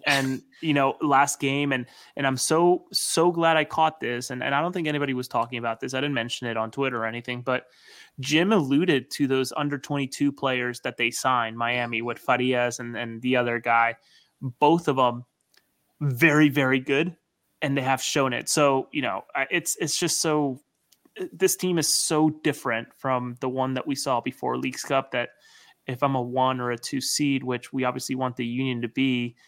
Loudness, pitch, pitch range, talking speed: -25 LUFS, 135 Hz, 125-145 Hz, 205 wpm